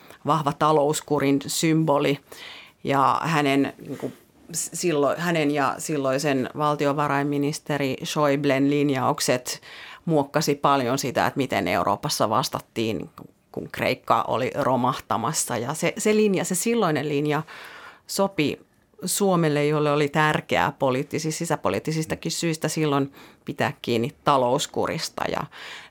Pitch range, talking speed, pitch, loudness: 140-155 Hz, 105 wpm, 145 Hz, -23 LUFS